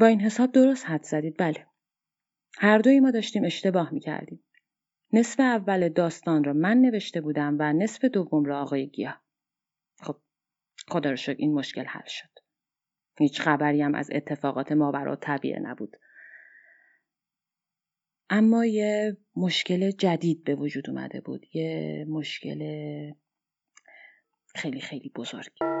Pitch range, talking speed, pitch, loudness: 150-215 Hz, 130 wpm, 165 Hz, -26 LUFS